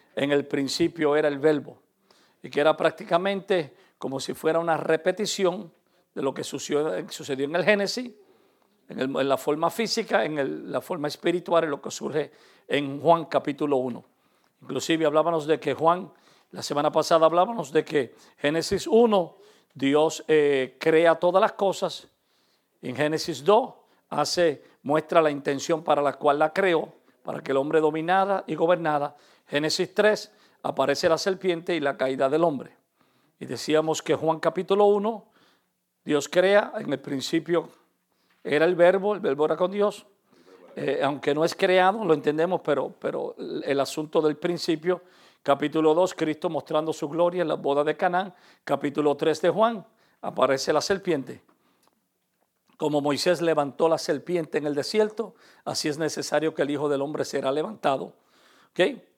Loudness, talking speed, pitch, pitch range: -25 LUFS, 160 wpm, 160 Hz, 150-185 Hz